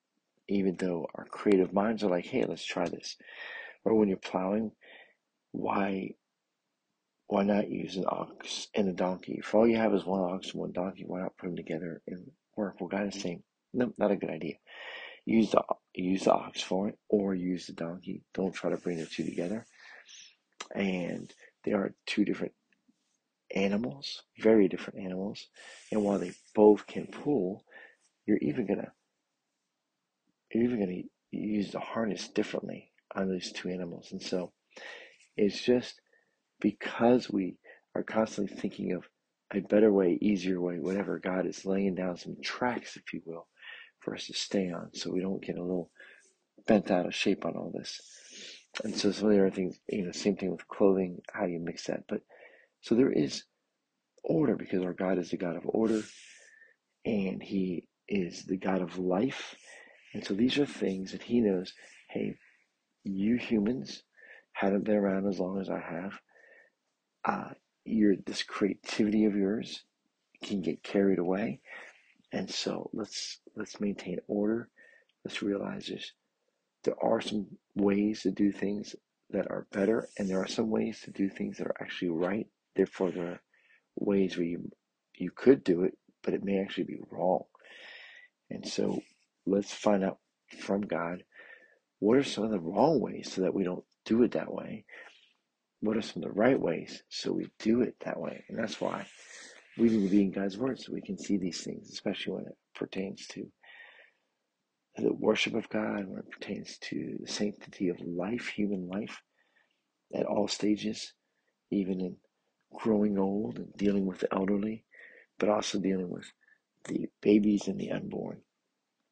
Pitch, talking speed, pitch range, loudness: 100 Hz, 175 wpm, 95-105 Hz, -32 LUFS